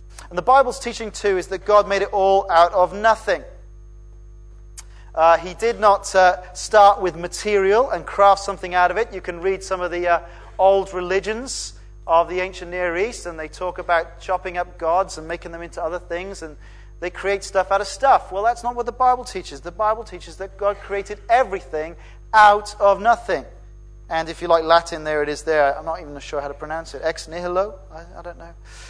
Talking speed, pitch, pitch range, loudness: 210 wpm, 180 Hz, 165-200 Hz, -20 LUFS